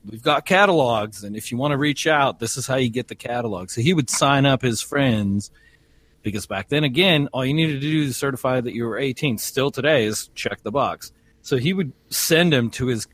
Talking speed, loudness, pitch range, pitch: 235 wpm, -21 LUFS, 115-150 Hz, 130 Hz